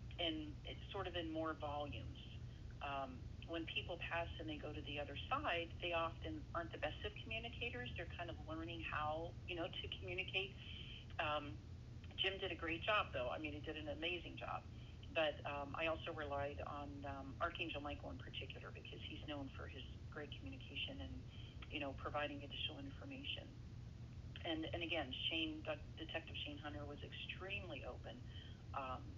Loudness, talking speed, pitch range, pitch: -46 LUFS, 170 wpm, 105-145 Hz, 115 Hz